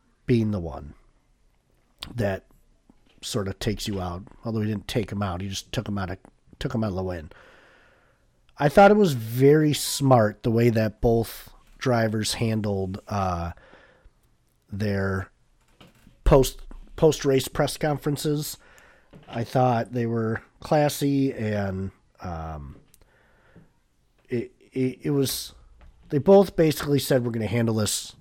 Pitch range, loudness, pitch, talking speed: 95-135 Hz, -24 LUFS, 115 Hz, 140 wpm